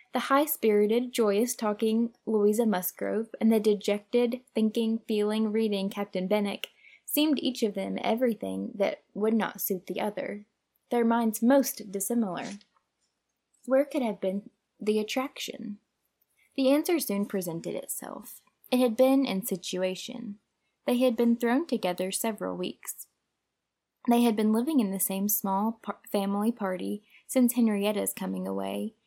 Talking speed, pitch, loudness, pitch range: 140 wpm, 220 Hz, -28 LUFS, 200-240 Hz